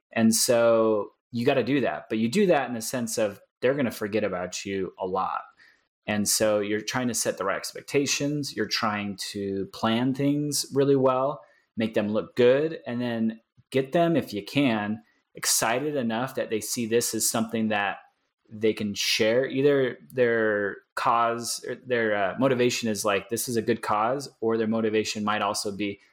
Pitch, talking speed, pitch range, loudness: 115 Hz, 190 wpm, 105-125 Hz, -26 LUFS